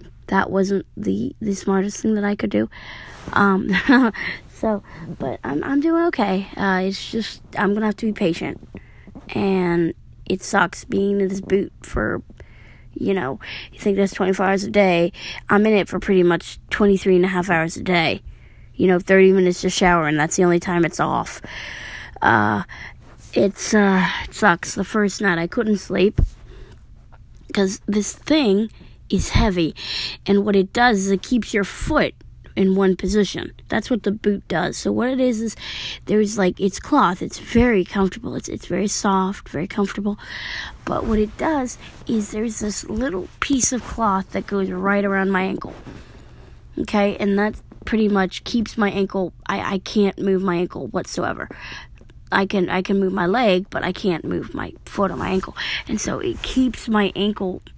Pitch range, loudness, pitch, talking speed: 185-210 Hz, -20 LUFS, 195 Hz, 180 wpm